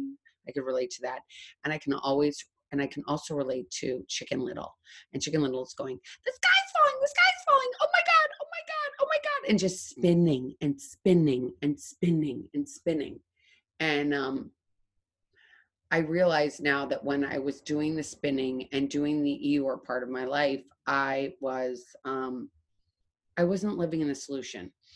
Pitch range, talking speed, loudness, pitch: 135-190 Hz, 180 wpm, -28 LUFS, 145 Hz